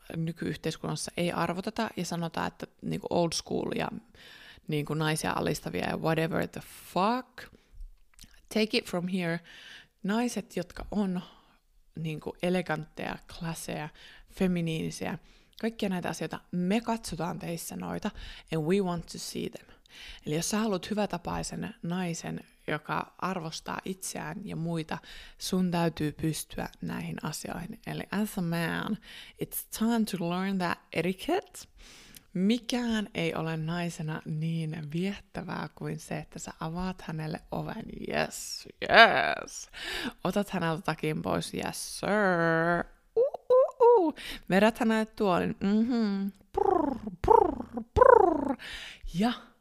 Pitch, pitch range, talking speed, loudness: 185 Hz, 165-220 Hz, 125 wpm, -30 LUFS